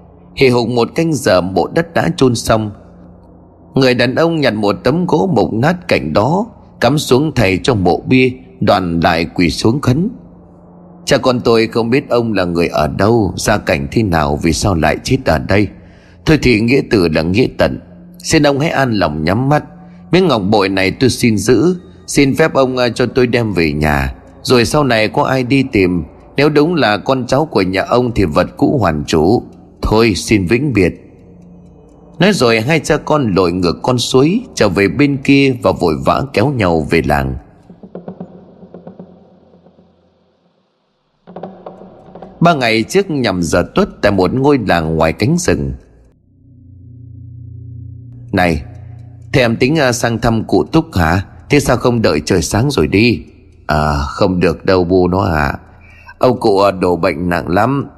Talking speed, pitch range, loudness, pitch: 175 wpm, 90-145 Hz, -13 LUFS, 115 Hz